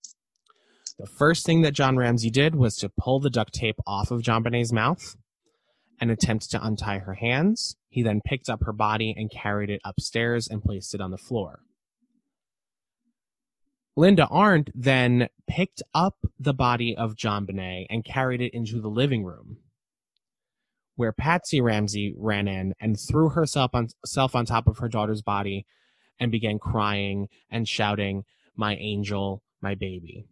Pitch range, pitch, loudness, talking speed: 105-135 Hz, 115 Hz, -25 LUFS, 160 wpm